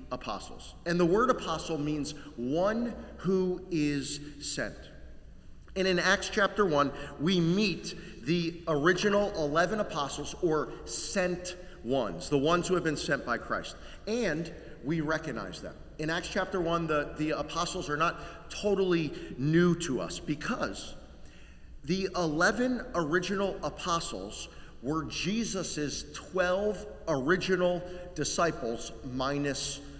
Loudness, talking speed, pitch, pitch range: -31 LUFS, 120 wpm, 165 Hz, 145-180 Hz